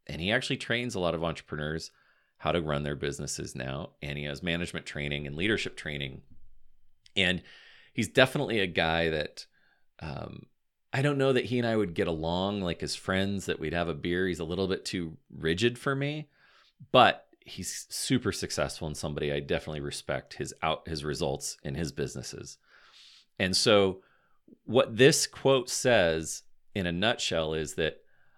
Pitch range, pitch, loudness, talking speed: 75-110 Hz, 85 Hz, -29 LUFS, 175 wpm